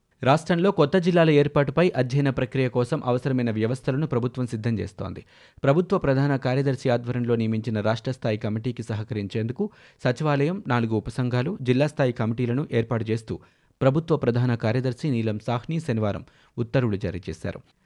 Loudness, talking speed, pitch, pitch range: -24 LUFS, 130 wpm, 125 Hz, 115-140 Hz